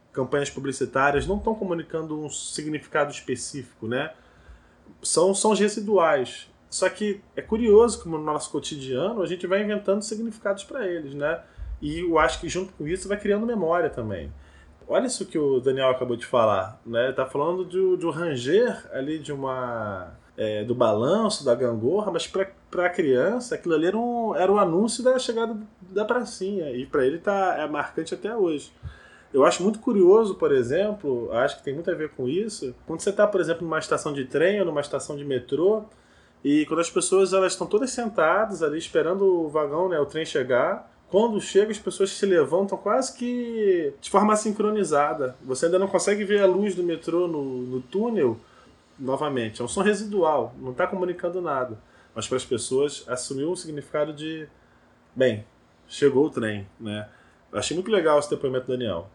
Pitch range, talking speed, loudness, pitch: 140-205 Hz, 185 wpm, -24 LUFS, 175 Hz